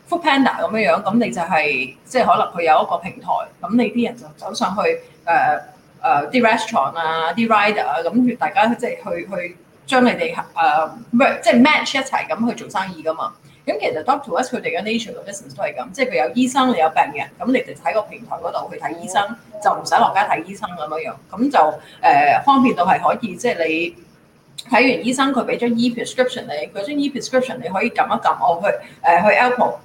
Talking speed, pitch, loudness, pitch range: 420 characters per minute, 235 Hz, -18 LUFS, 190-255 Hz